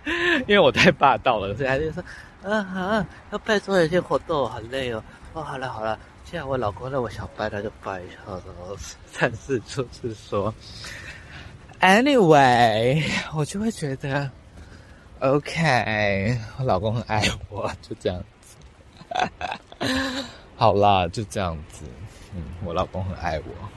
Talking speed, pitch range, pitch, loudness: 225 characters per minute, 95-145 Hz, 110 Hz, -23 LUFS